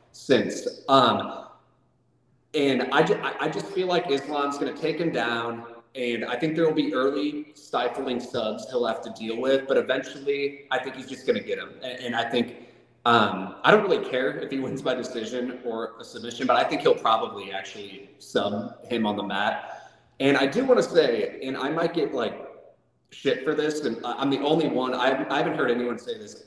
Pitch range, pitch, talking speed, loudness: 120-155 Hz, 135 Hz, 205 wpm, -25 LUFS